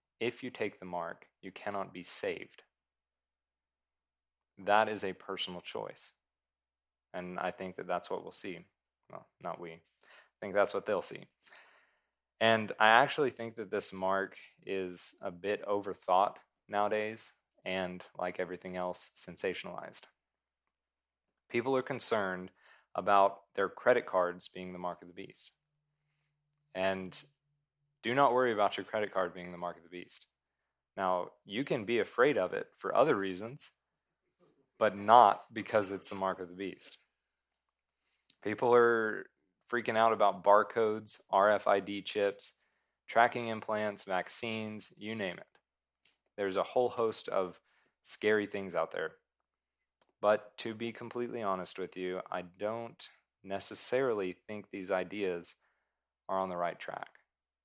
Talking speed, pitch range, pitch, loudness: 140 wpm, 90-110 Hz, 100 Hz, -33 LUFS